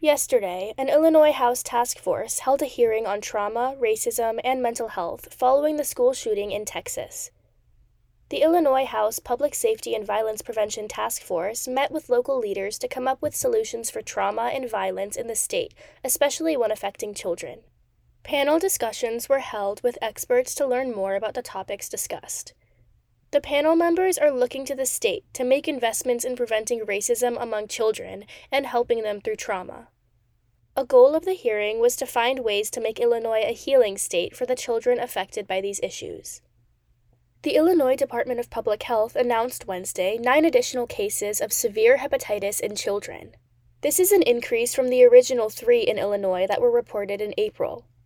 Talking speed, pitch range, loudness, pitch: 170 wpm, 215-310 Hz, -23 LUFS, 245 Hz